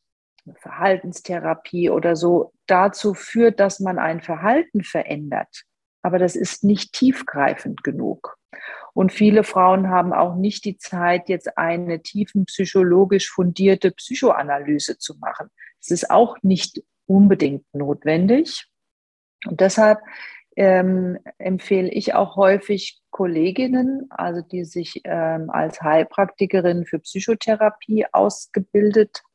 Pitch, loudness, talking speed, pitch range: 190 Hz, -19 LUFS, 115 wpm, 175-210 Hz